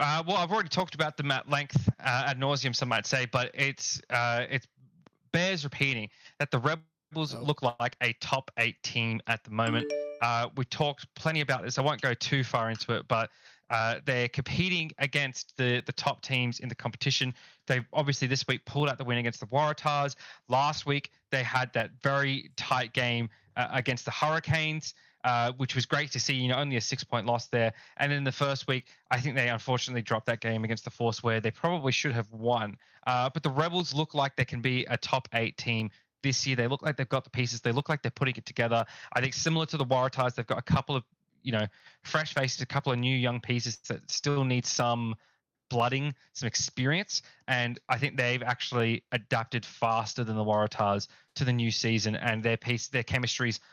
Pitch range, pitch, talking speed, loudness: 120-140 Hz, 130 Hz, 215 wpm, -30 LUFS